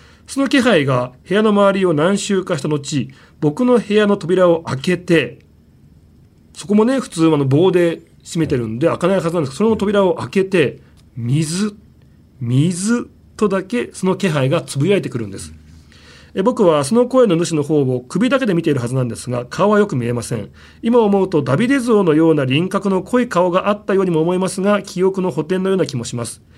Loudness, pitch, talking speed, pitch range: -16 LUFS, 175 Hz, 365 characters per minute, 130-200 Hz